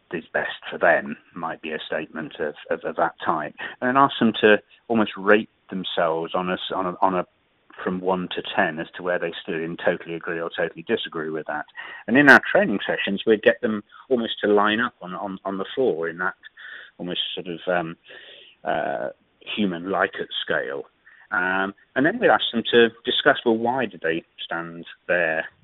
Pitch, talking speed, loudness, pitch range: 95 Hz, 200 wpm, -23 LUFS, 90-115 Hz